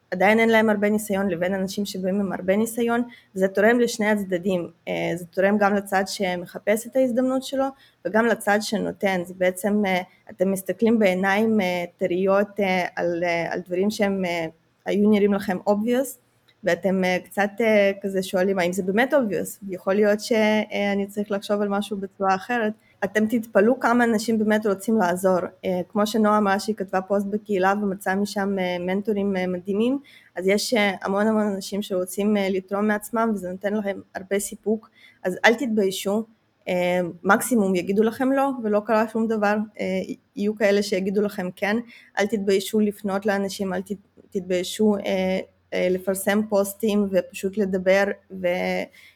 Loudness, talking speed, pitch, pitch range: -23 LUFS, 140 wpm, 200 Hz, 190-215 Hz